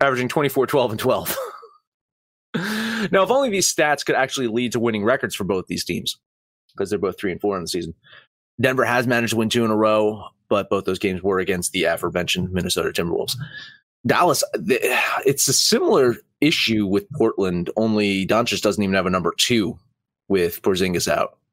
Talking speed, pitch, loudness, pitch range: 185 wpm, 115 Hz, -20 LUFS, 100-140 Hz